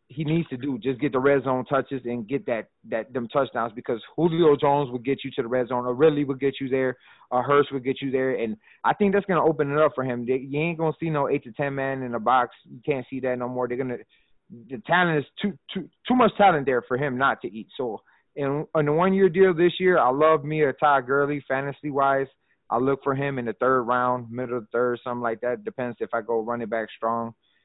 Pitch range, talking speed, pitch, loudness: 125-150 Hz, 260 wpm, 135 Hz, -24 LUFS